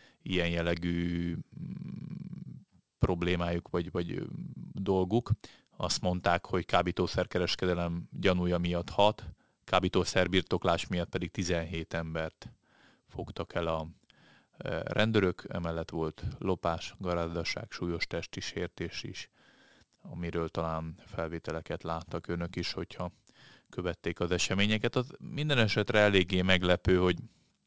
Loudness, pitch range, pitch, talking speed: -32 LUFS, 85-95 Hz, 90 Hz, 100 wpm